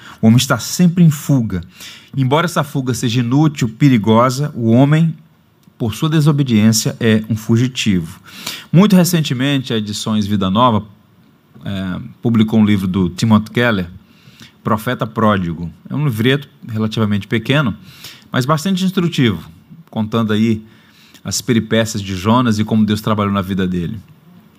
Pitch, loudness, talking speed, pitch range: 115 Hz, -15 LUFS, 135 wpm, 105-145 Hz